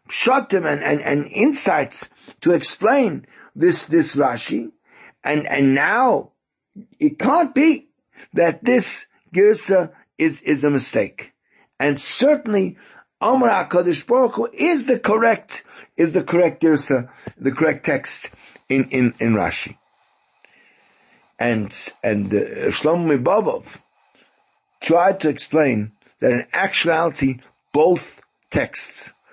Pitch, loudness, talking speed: 175 Hz, -19 LUFS, 110 wpm